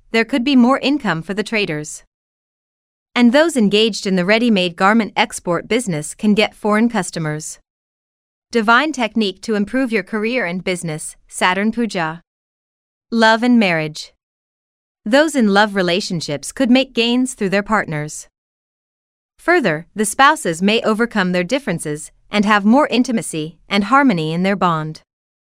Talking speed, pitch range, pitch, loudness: 145 wpm, 175-235 Hz, 210 Hz, -16 LUFS